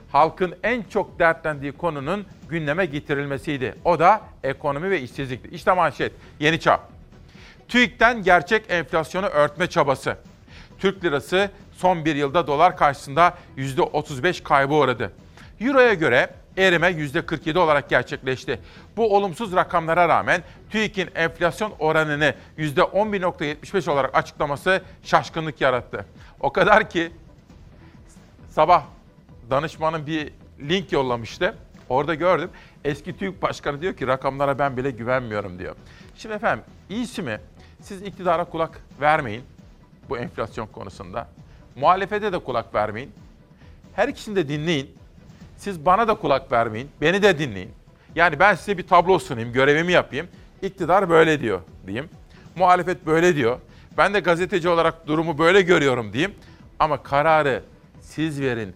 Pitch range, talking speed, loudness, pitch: 140-185 Hz, 125 wpm, -21 LUFS, 165 Hz